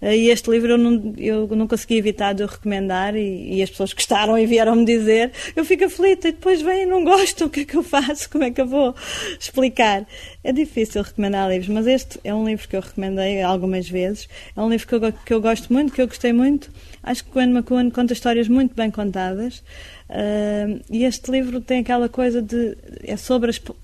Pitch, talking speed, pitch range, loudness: 235 Hz, 220 wpm, 210-260 Hz, -19 LUFS